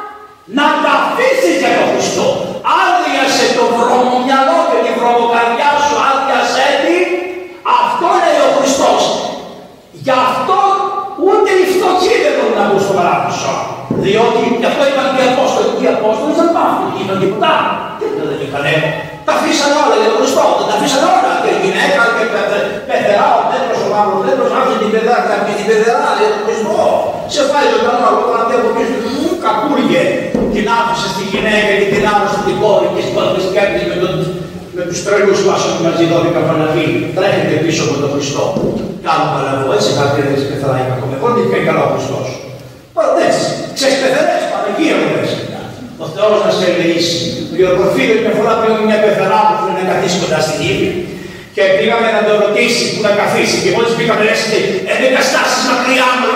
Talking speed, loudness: 125 wpm, -12 LUFS